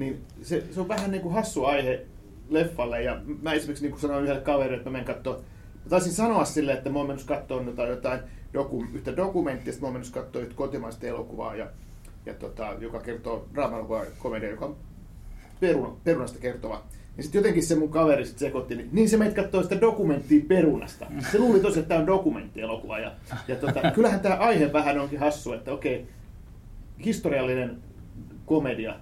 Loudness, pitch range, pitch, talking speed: -27 LUFS, 120-165 Hz, 140 Hz, 185 wpm